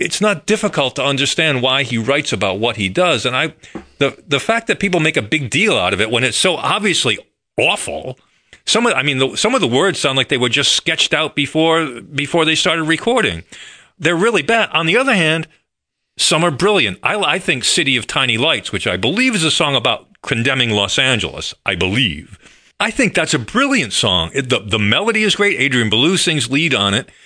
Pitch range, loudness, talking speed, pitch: 130-175 Hz, -15 LUFS, 220 wpm, 155 Hz